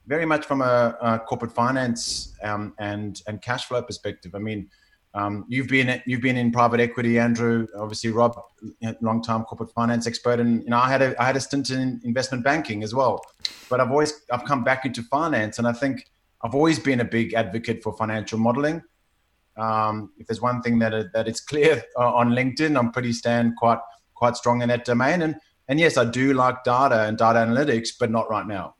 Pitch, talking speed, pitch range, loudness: 120 Hz, 210 wpm, 110-130 Hz, -23 LUFS